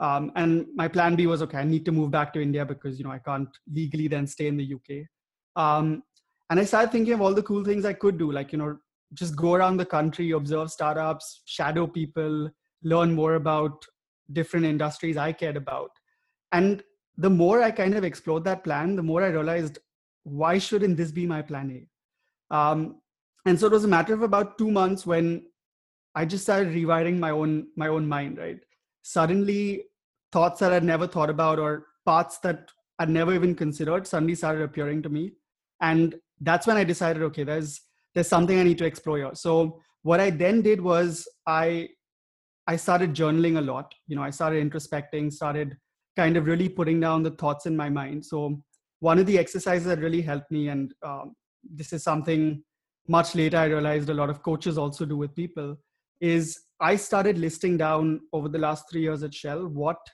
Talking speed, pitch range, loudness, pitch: 200 wpm, 150-175 Hz, -25 LUFS, 160 Hz